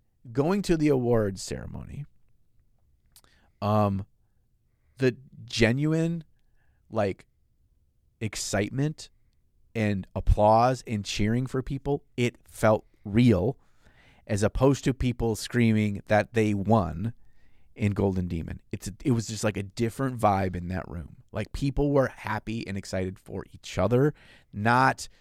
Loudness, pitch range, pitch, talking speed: -27 LUFS, 100-130 Hz, 110 Hz, 120 wpm